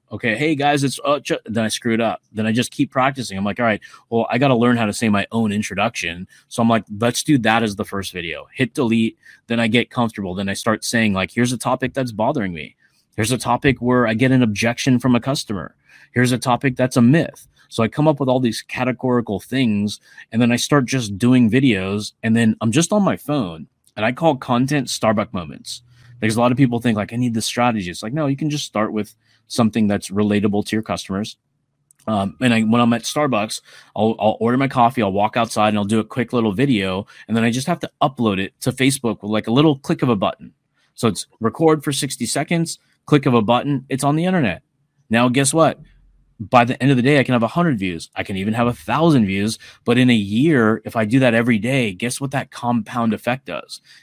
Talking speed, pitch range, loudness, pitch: 245 wpm, 110-135 Hz, -19 LUFS, 120 Hz